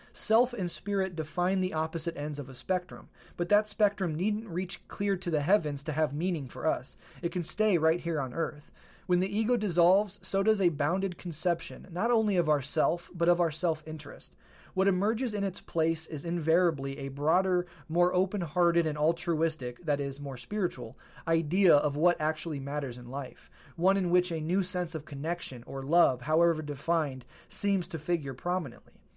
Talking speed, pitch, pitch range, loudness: 185 wpm, 170 Hz, 150-185 Hz, -30 LUFS